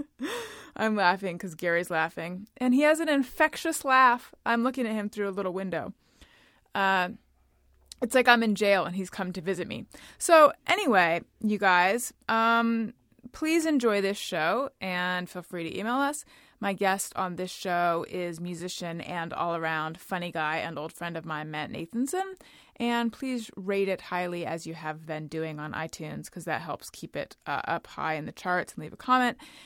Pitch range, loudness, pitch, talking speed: 170-240 Hz, -28 LUFS, 190 Hz, 185 wpm